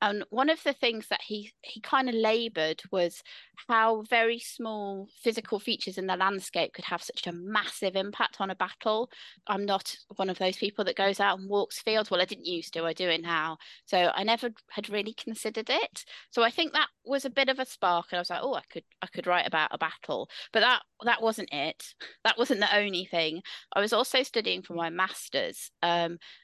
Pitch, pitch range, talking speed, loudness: 205 Hz, 185-230 Hz, 220 wpm, -29 LUFS